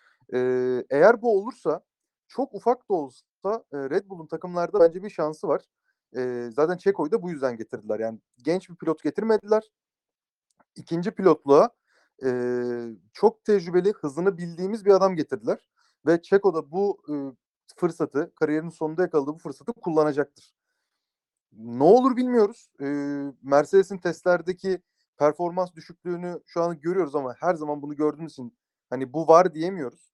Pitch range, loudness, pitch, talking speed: 145-195 Hz, -25 LUFS, 165 Hz, 125 wpm